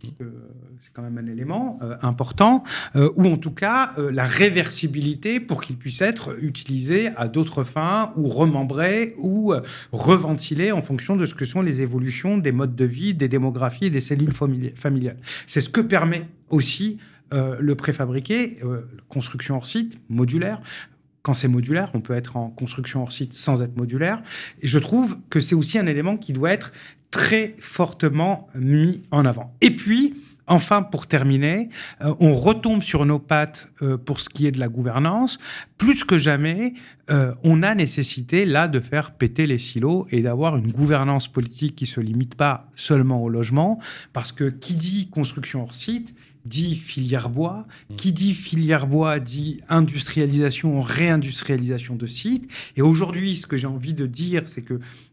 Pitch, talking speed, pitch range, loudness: 145 Hz, 175 wpm, 130-175 Hz, -22 LUFS